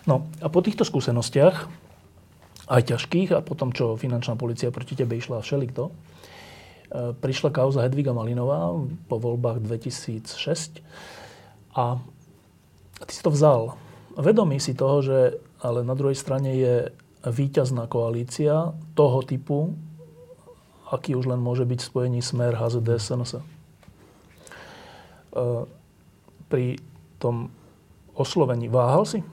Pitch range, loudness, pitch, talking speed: 120-150 Hz, -24 LUFS, 130 Hz, 115 wpm